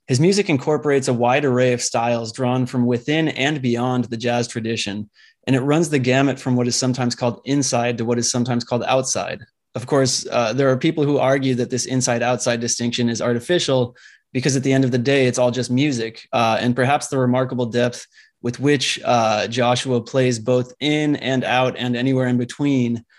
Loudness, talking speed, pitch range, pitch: -19 LUFS, 200 wpm, 120-135 Hz, 125 Hz